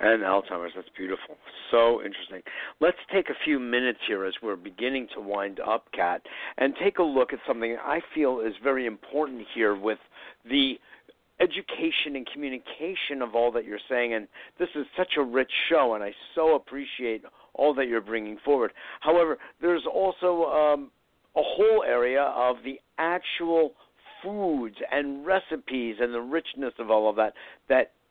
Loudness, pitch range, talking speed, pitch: -27 LUFS, 115-155 Hz, 165 wpm, 130 Hz